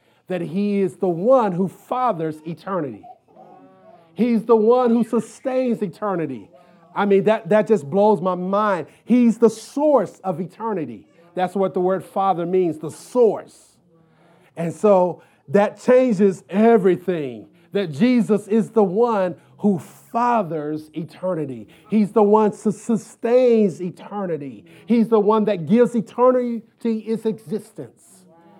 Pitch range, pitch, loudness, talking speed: 170-225 Hz, 200 Hz, -20 LUFS, 130 wpm